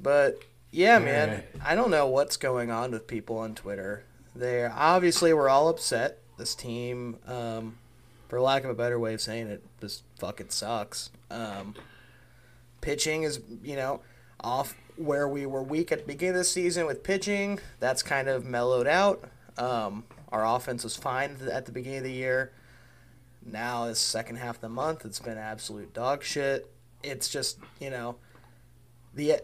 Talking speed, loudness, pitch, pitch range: 170 wpm, -29 LUFS, 125 Hz, 115-140 Hz